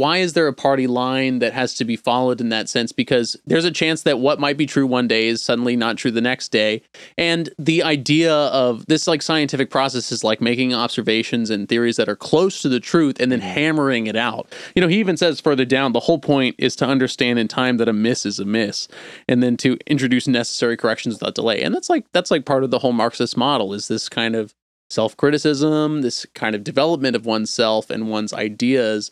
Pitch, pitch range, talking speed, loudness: 125 Hz, 115-150 Hz, 230 wpm, -19 LUFS